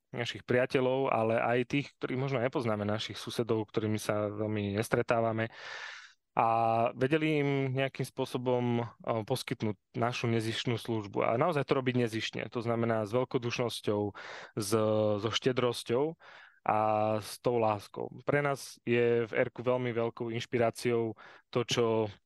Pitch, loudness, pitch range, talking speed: 115 Hz, -32 LUFS, 110-125 Hz, 130 wpm